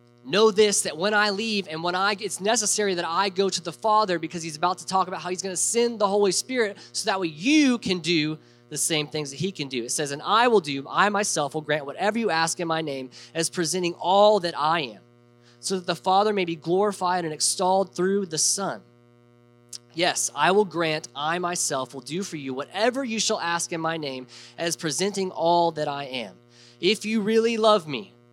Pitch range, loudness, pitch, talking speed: 150-200 Hz, -24 LUFS, 175 Hz, 225 wpm